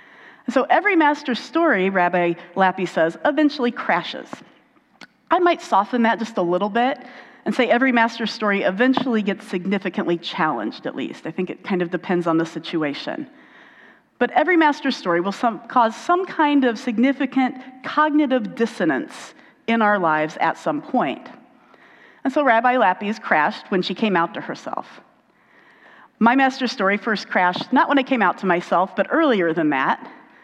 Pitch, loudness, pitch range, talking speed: 240 Hz, -20 LUFS, 190-275 Hz, 165 wpm